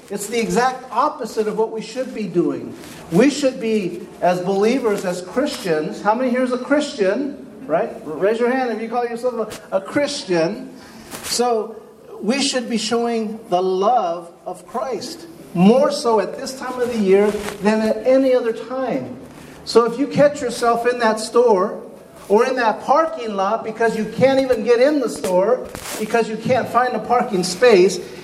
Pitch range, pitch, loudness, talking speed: 215-255 Hz, 230 Hz, -19 LUFS, 180 wpm